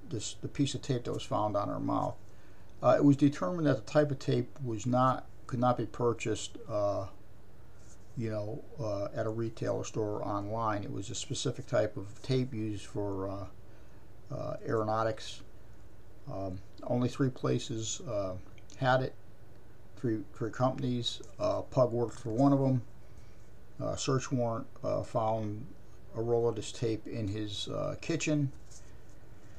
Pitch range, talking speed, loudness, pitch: 105-125 Hz, 160 wpm, -33 LUFS, 115 Hz